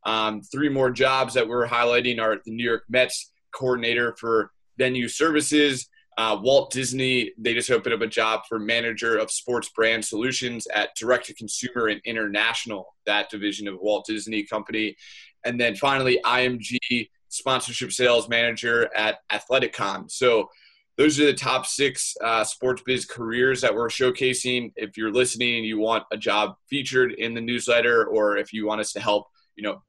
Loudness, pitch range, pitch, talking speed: -23 LUFS, 110-130 Hz, 120 Hz, 175 wpm